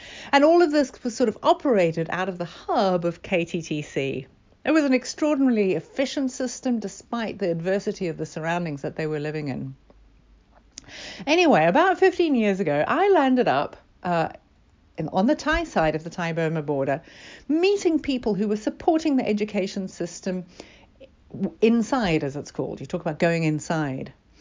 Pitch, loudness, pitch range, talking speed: 195 Hz, -23 LUFS, 165-275 Hz, 165 wpm